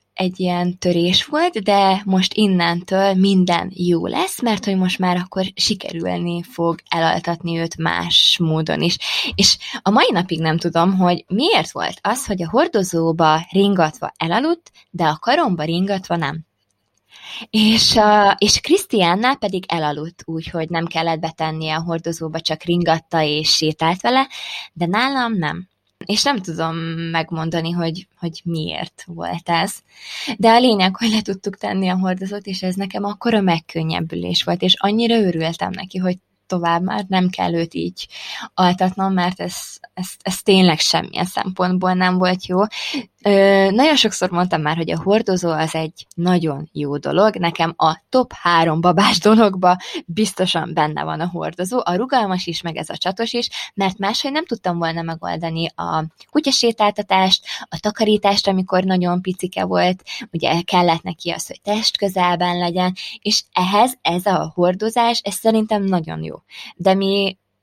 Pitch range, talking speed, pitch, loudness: 165-205 Hz, 155 wpm, 185 Hz, -18 LUFS